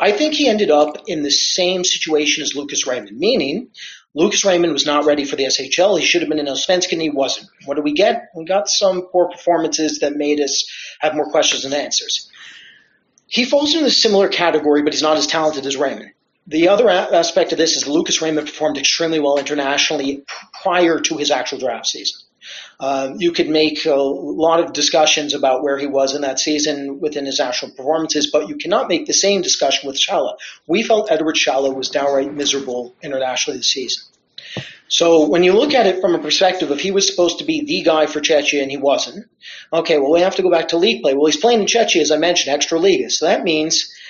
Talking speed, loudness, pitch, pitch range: 220 wpm, -16 LUFS, 155 Hz, 145-180 Hz